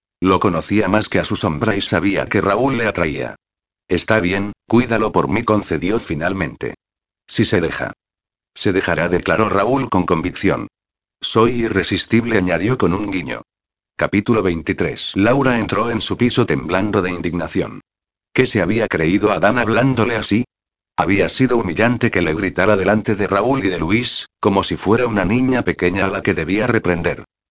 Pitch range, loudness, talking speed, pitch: 90-115 Hz, -17 LUFS, 165 wpm, 100 Hz